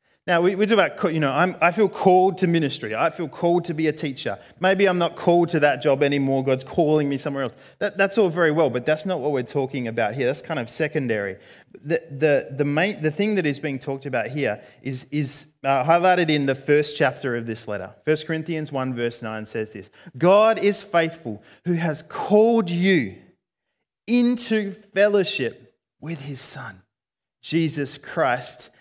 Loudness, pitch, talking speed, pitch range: -22 LUFS, 155 Hz, 195 wpm, 135-180 Hz